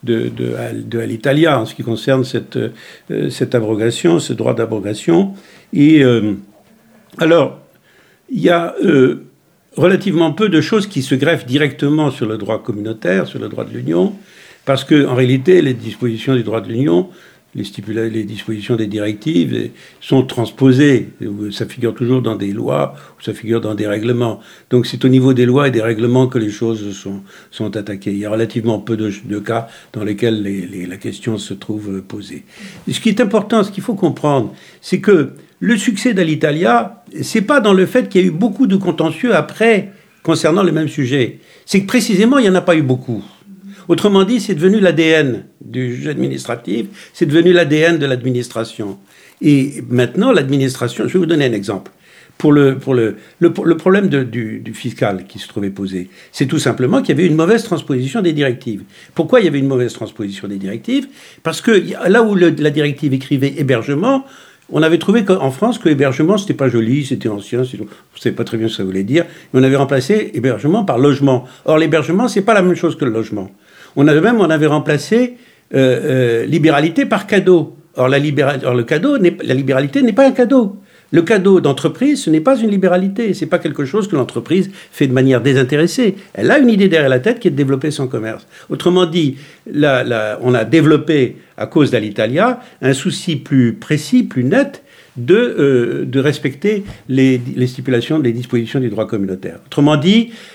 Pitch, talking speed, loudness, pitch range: 140 Hz, 195 wpm, -15 LUFS, 115-180 Hz